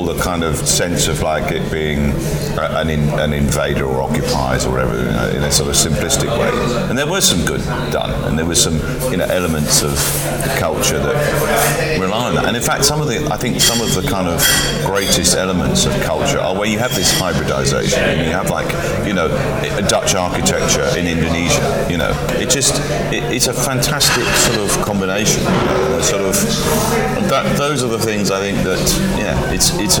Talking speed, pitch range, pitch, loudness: 205 wpm, 70-90 Hz, 75 Hz, -15 LUFS